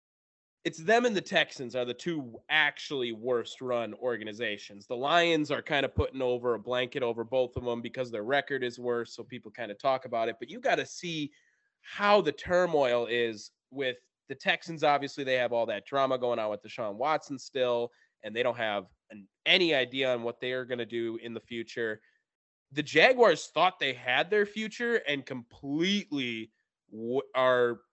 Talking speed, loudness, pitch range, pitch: 190 wpm, -29 LUFS, 120-150 Hz, 125 Hz